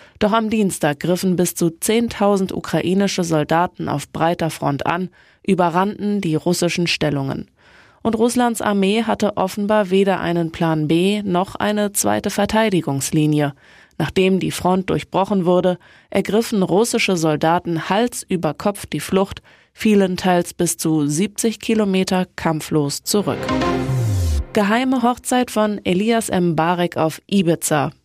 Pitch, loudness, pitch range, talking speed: 180 Hz, -19 LUFS, 160-205 Hz, 125 wpm